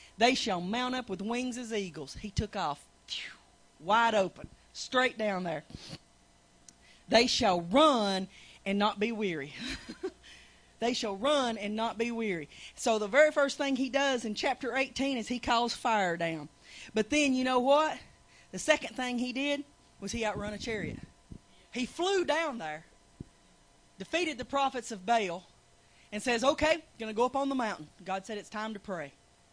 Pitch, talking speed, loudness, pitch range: 230 Hz, 175 wpm, -31 LUFS, 205-265 Hz